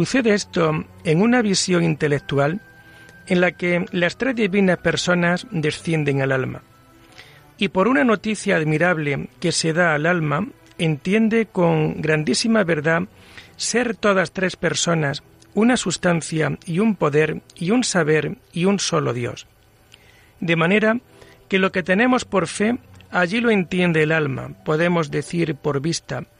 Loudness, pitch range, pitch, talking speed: -20 LUFS, 155-195 Hz, 170 Hz, 145 wpm